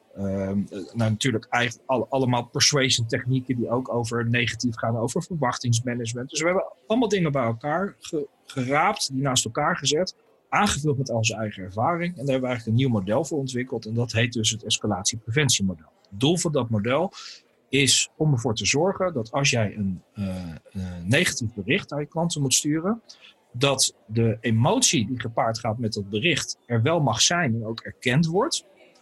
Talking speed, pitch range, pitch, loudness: 180 wpm, 110-145 Hz, 120 Hz, -24 LUFS